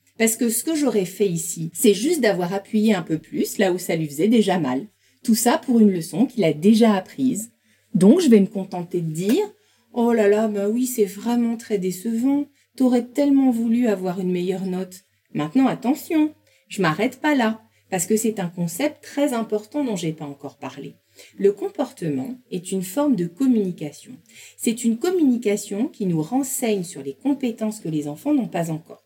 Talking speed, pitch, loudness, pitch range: 190 wpm, 220 Hz, -21 LUFS, 185-255 Hz